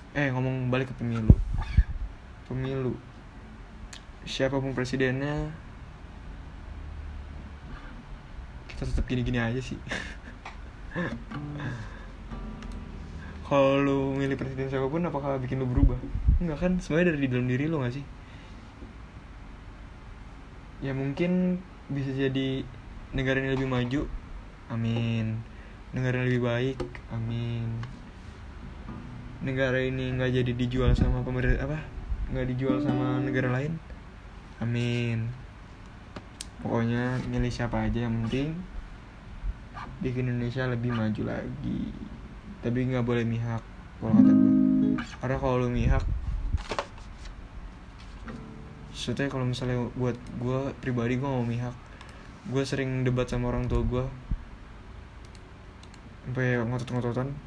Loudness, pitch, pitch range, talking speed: -29 LUFS, 125 Hz, 110-135 Hz, 100 wpm